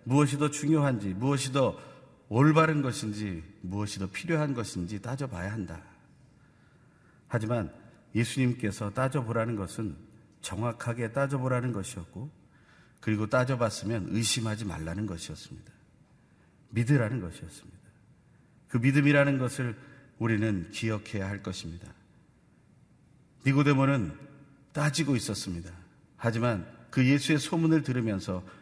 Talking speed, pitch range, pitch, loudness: 295 characters per minute, 105-140 Hz, 120 Hz, -29 LUFS